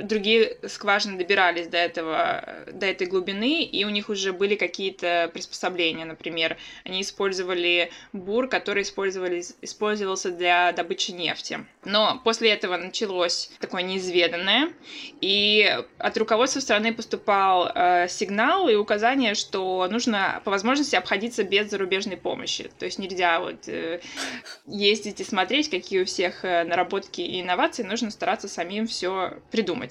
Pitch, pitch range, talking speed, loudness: 195 Hz, 180-225 Hz, 130 wpm, -24 LUFS